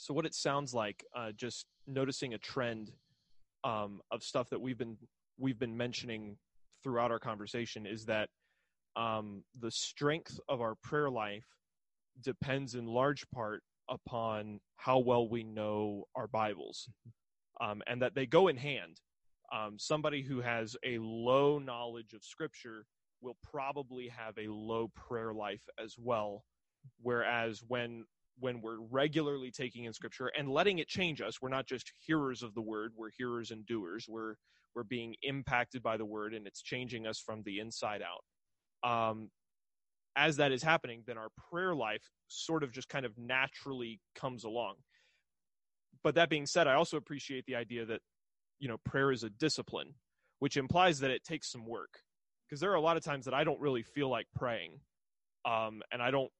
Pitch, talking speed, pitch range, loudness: 120 Hz, 175 wpm, 110-135 Hz, -37 LUFS